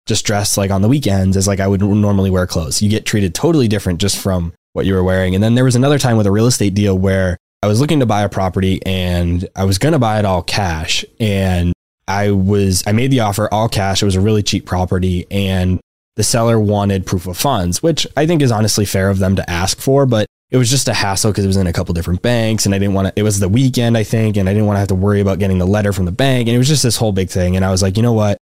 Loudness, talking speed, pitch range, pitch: -15 LUFS, 295 wpm, 95-110 Hz, 100 Hz